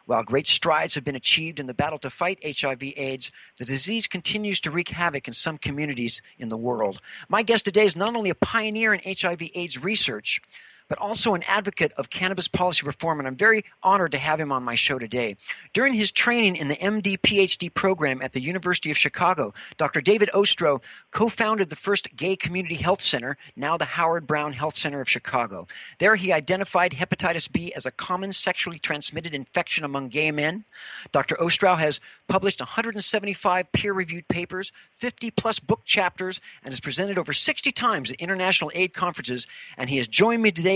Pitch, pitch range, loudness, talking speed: 175 Hz, 150-200 Hz, -23 LUFS, 190 wpm